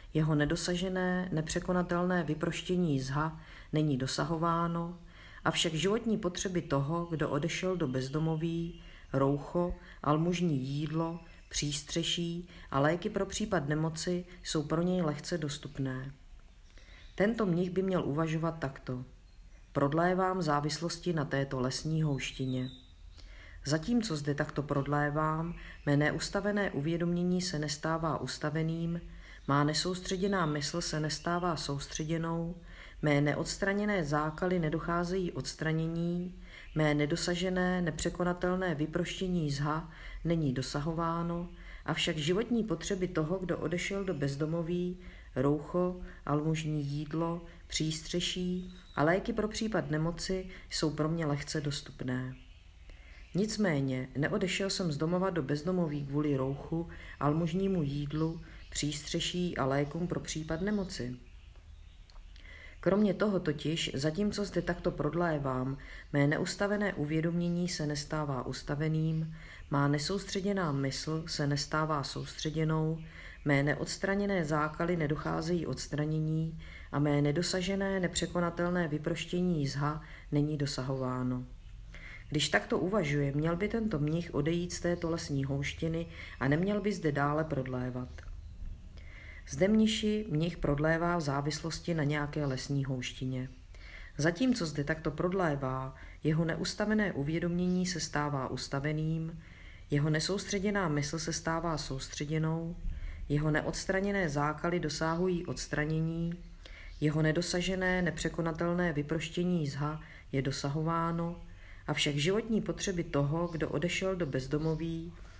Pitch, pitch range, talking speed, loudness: 160 Hz, 145-175 Hz, 105 wpm, -32 LUFS